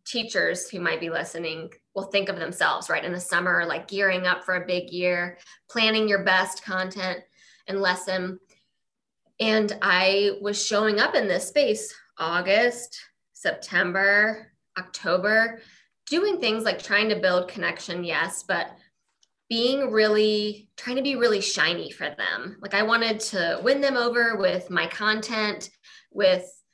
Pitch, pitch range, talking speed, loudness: 200 Hz, 185-220 Hz, 150 wpm, -24 LUFS